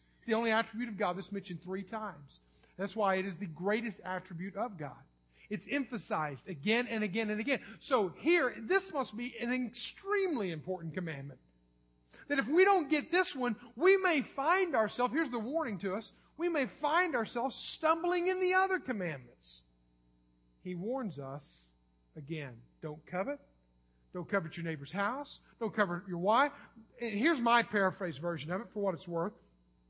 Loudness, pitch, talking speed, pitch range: -34 LUFS, 210 Hz, 170 wpm, 165-255 Hz